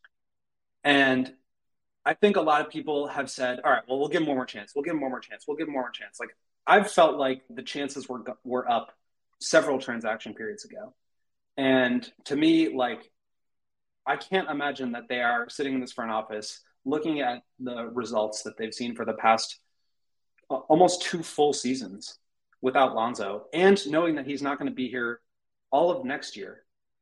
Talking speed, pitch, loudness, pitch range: 200 wpm, 130 Hz, -27 LUFS, 120-150 Hz